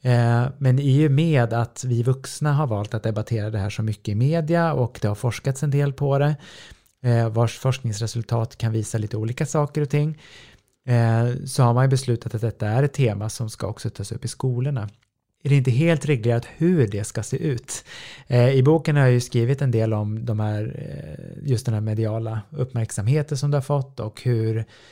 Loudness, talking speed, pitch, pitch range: -22 LUFS, 200 wpm, 120 Hz, 115-140 Hz